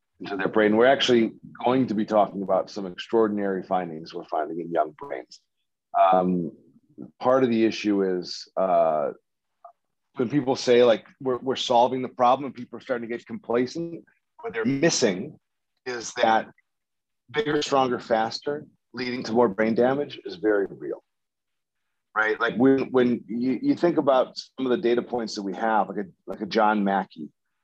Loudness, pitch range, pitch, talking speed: -24 LUFS, 105-130 Hz, 120 Hz, 170 wpm